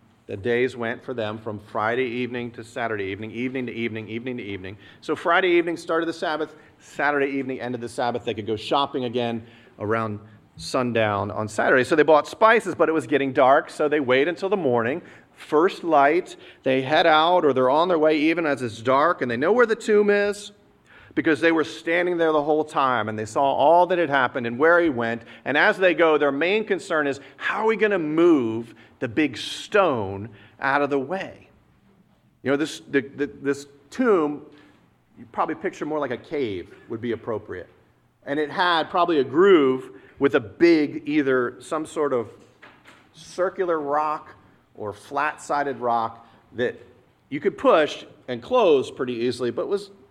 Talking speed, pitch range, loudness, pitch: 190 wpm, 120-165 Hz, -22 LUFS, 140 Hz